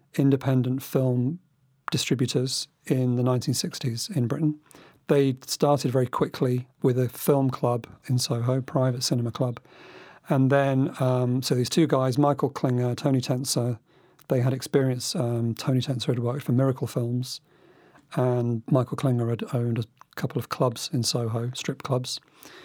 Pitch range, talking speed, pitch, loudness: 125-140 Hz, 150 wpm, 130 Hz, -26 LUFS